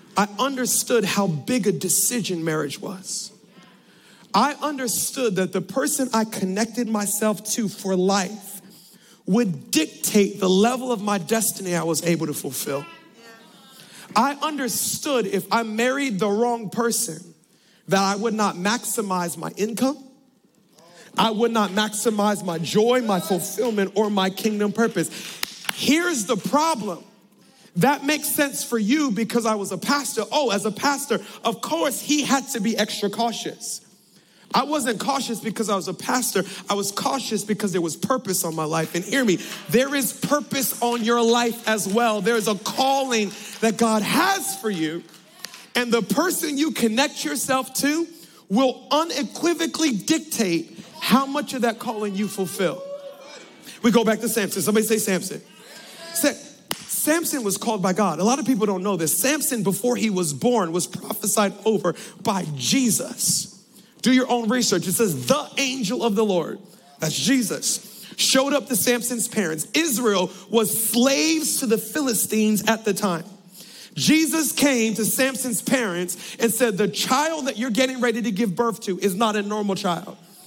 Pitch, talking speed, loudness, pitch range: 220 Hz, 165 wpm, -22 LUFS, 195-250 Hz